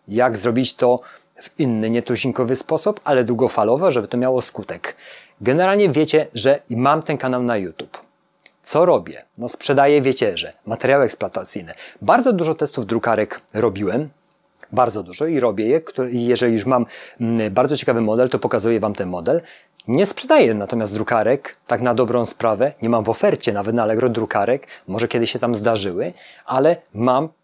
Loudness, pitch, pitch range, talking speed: -19 LUFS, 125 Hz, 115-140 Hz, 160 wpm